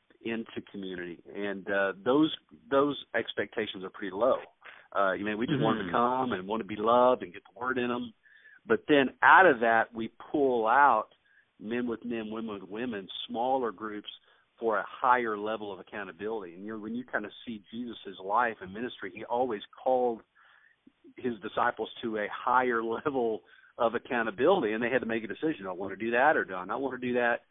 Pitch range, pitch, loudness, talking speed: 105-125 Hz, 115 Hz, -29 LUFS, 205 wpm